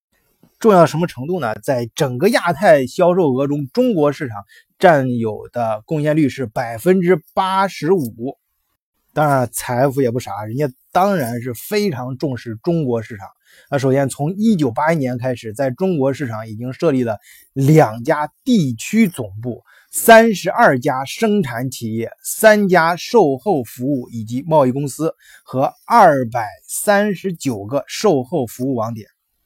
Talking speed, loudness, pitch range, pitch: 230 characters per minute, -17 LUFS, 125-175 Hz, 140 Hz